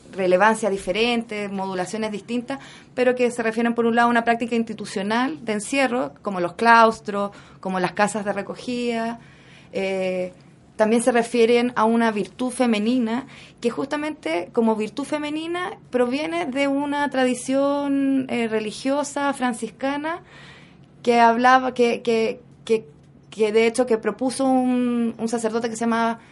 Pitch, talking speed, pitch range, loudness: 235 Hz, 140 wpm, 215-255 Hz, -22 LUFS